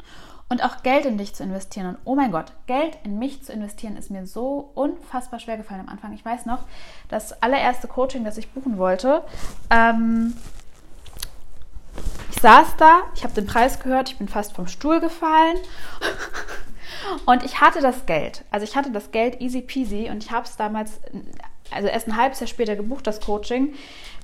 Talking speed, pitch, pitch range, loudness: 185 wpm, 245 Hz, 215-270 Hz, -21 LUFS